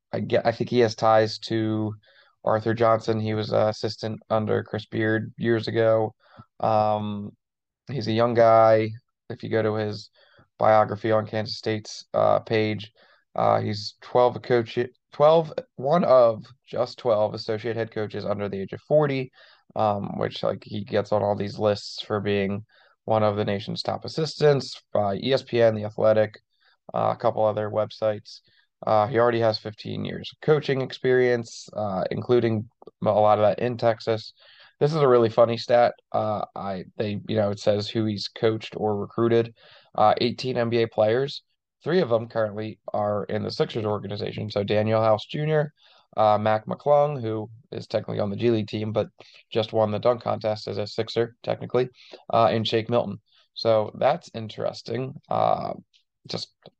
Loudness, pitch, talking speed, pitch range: -24 LUFS, 110 Hz, 170 wpm, 105-120 Hz